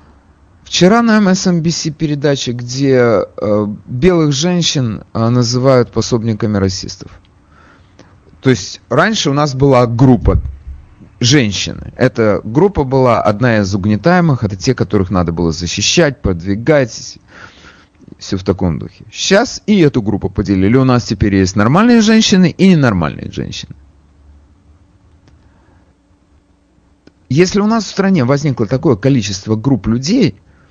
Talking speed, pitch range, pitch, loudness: 120 wpm, 95-145 Hz, 115 Hz, -13 LUFS